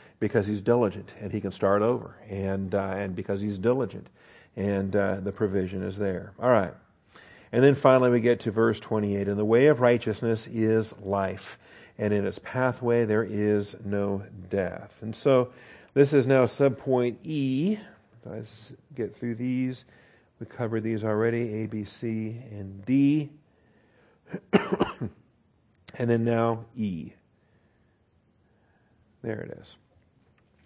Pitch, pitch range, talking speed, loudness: 110 Hz, 100-120 Hz, 140 wpm, -26 LUFS